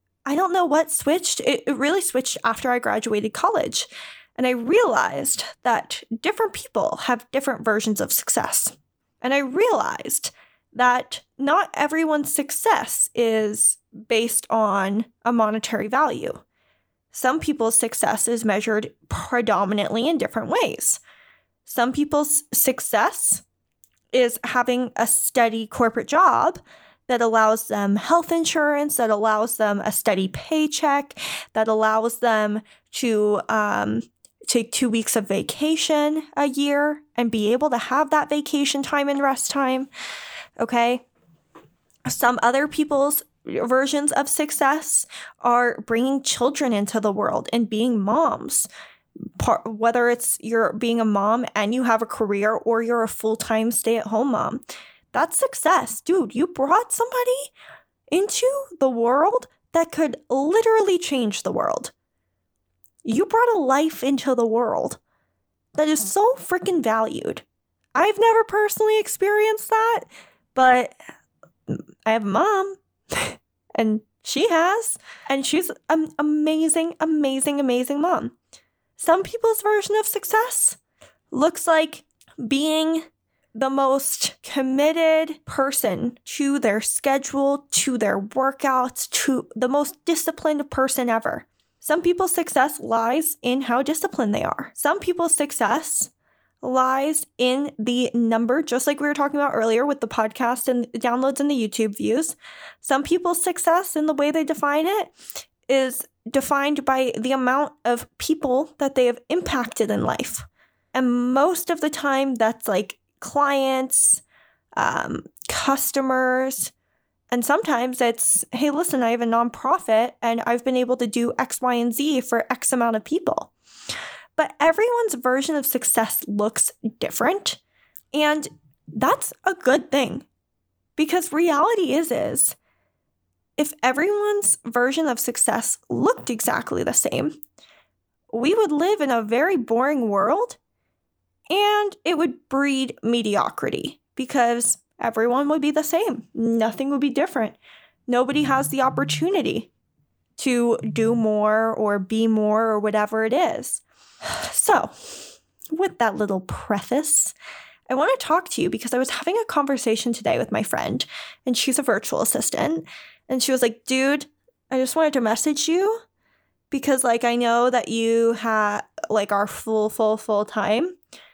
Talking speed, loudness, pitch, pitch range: 140 wpm, -21 LUFS, 265 Hz, 230-310 Hz